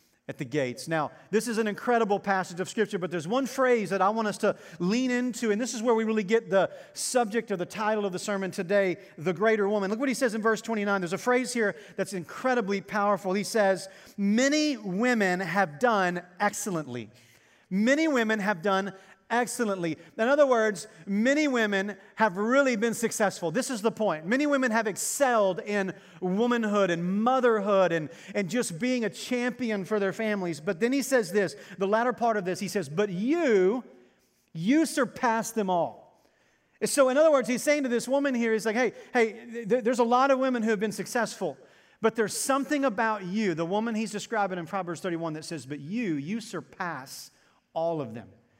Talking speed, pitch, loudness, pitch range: 200 wpm, 210 Hz, -27 LUFS, 190-240 Hz